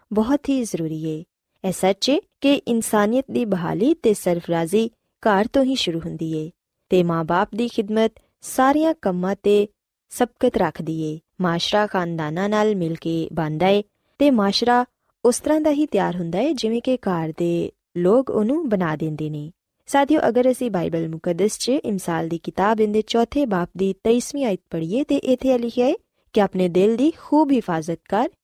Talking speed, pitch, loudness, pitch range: 165 wpm, 205 Hz, -21 LUFS, 175-250 Hz